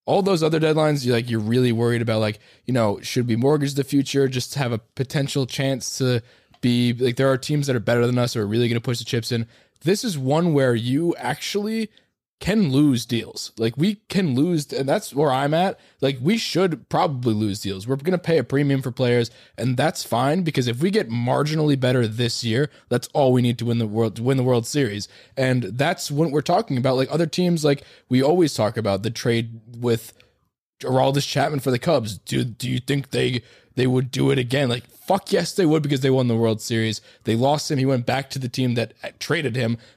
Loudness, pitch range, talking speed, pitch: -22 LUFS, 120-145 Hz, 235 wpm, 130 Hz